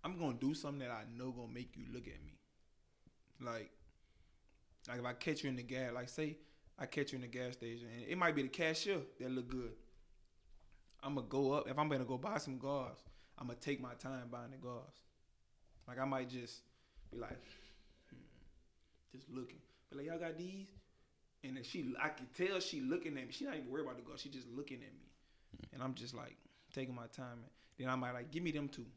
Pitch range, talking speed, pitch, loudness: 120-145 Hz, 225 wpm, 130 Hz, -44 LUFS